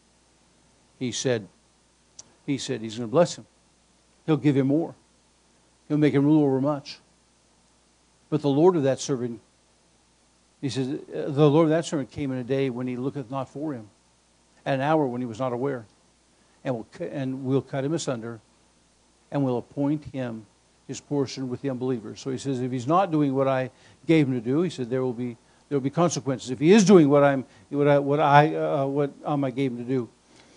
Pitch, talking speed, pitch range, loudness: 135 Hz, 205 wpm, 120-145 Hz, -25 LUFS